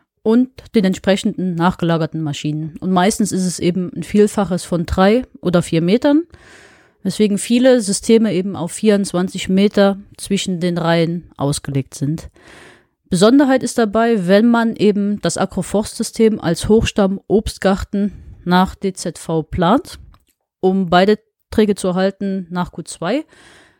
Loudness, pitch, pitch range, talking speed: -17 LUFS, 190 Hz, 175-215 Hz, 125 wpm